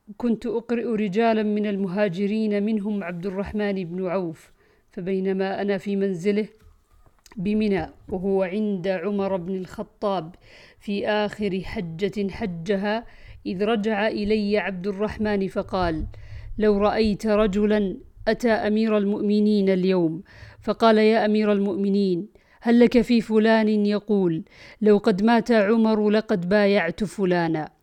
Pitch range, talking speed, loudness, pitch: 195-215 Hz, 115 wpm, -23 LUFS, 205 Hz